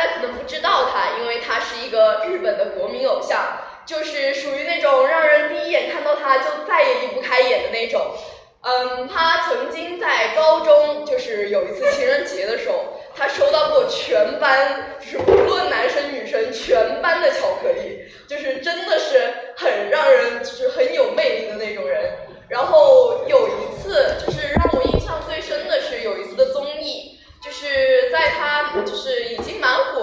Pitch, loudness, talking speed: 325 Hz, -19 LUFS, 260 characters per minute